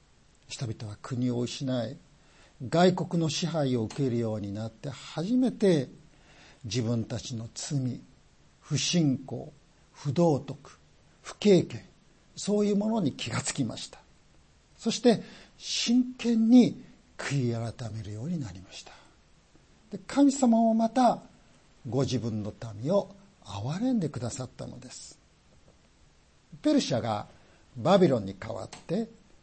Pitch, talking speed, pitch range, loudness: 145 Hz, 225 characters per minute, 120-195 Hz, -28 LUFS